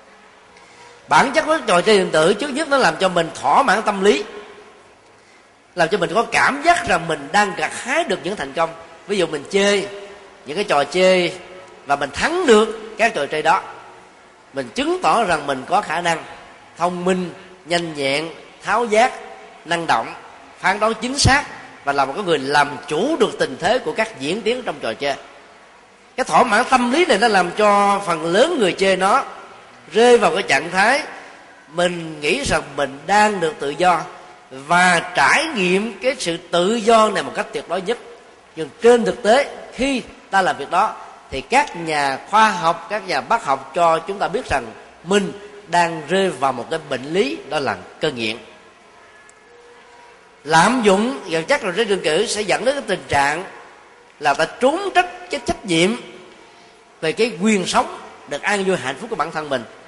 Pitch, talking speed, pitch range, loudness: 190 Hz, 195 wpm, 165-230 Hz, -18 LUFS